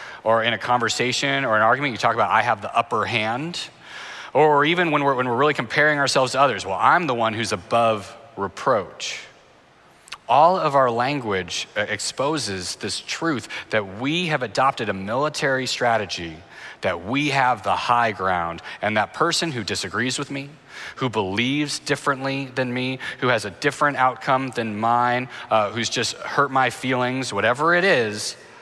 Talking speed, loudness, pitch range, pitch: 170 wpm, -21 LUFS, 115-145 Hz, 130 Hz